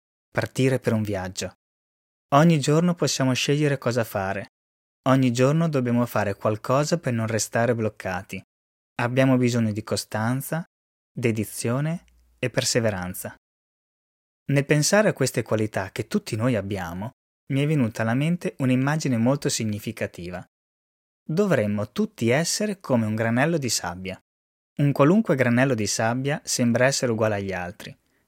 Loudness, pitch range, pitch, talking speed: -23 LUFS, 100-135 Hz, 120 Hz, 130 wpm